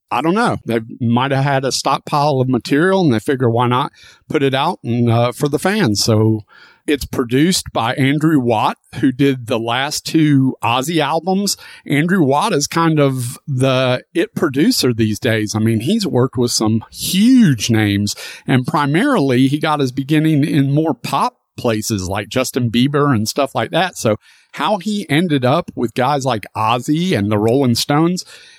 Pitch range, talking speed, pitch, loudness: 115-150 Hz, 180 wpm, 135 Hz, -16 LUFS